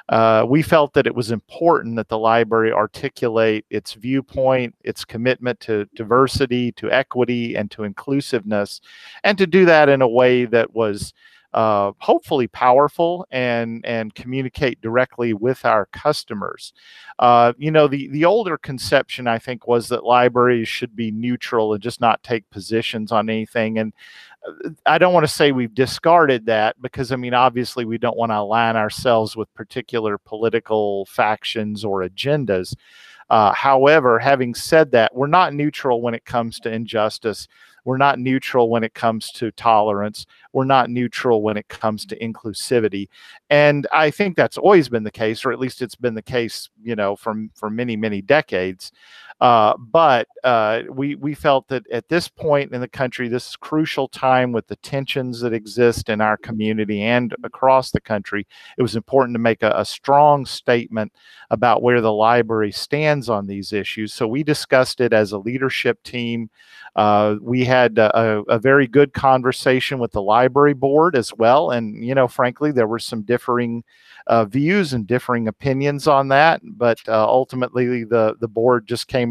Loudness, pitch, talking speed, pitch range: -18 LUFS, 120 Hz, 175 wpm, 110-130 Hz